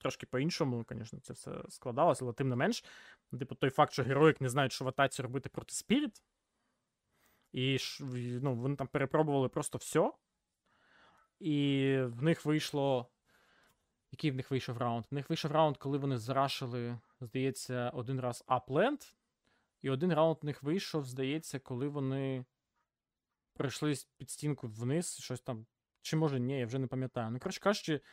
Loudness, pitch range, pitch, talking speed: -35 LUFS, 130-150 Hz, 135 Hz, 160 wpm